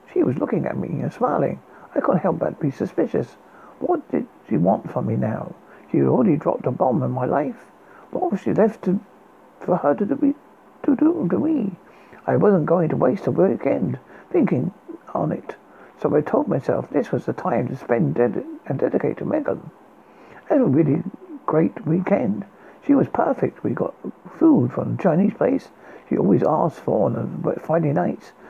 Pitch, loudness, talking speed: 205 Hz, -22 LUFS, 190 wpm